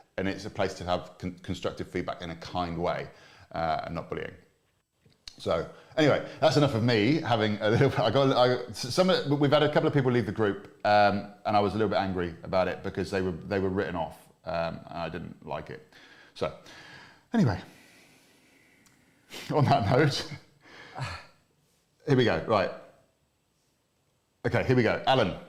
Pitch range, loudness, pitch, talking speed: 100-140 Hz, -28 LUFS, 110 Hz, 175 wpm